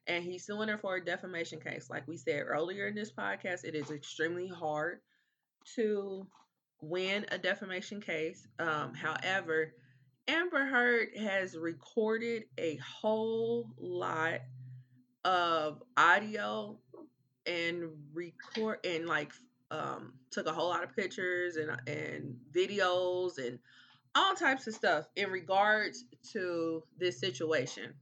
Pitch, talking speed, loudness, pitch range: 180 Hz, 125 wpm, -34 LUFS, 155-205 Hz